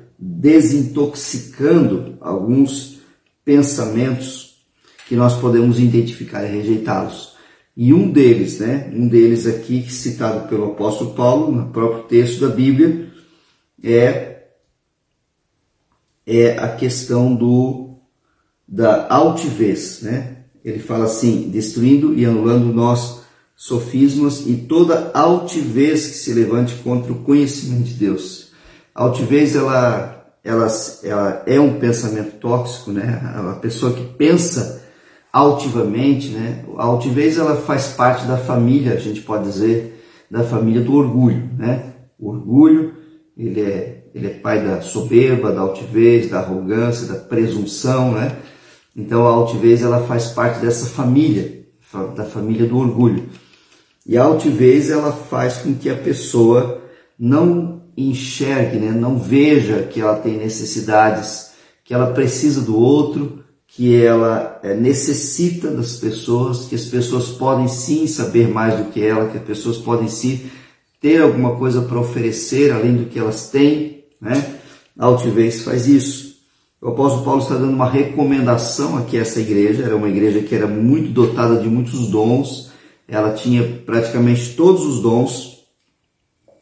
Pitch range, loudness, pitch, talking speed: 115-140 Hz, -16 LUFS, 120 Hz, 135 wpm